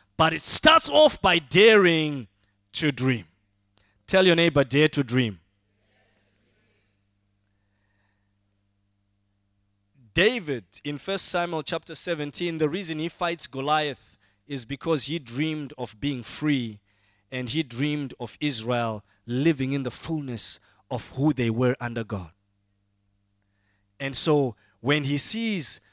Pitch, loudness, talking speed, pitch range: 125 Hz, -24 LUFS, 120 wpm, 100-155 Hz